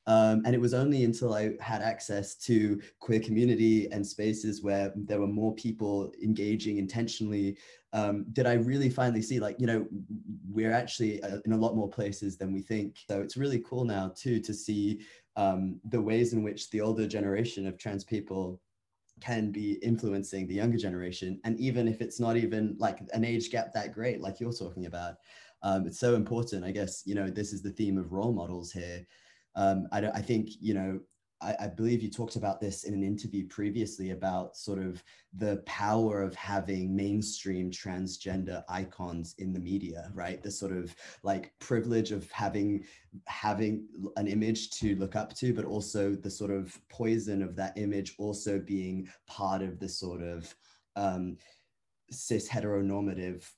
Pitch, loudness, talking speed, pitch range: 105 Hz, -32 LUFS, 180 wpm, 95-110 Hz